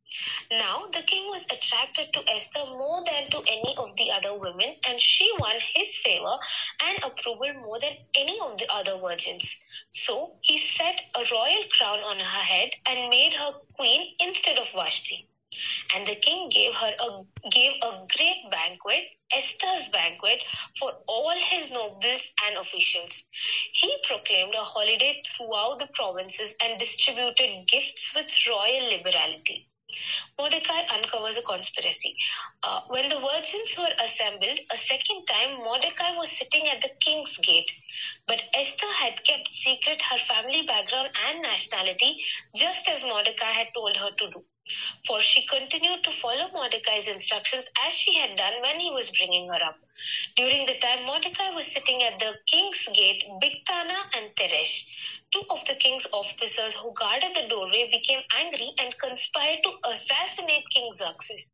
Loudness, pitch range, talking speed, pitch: -24 LUFS, 220-325 Hz, 155 wpm, 260 Hz